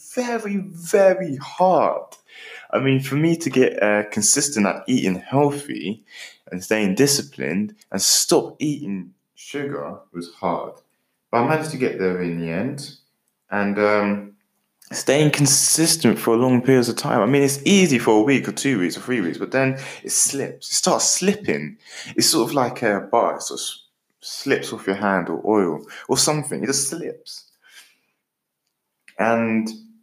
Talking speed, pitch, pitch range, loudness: 165 wpm, 130 Hz, 105-155 Hz, -20 LUFS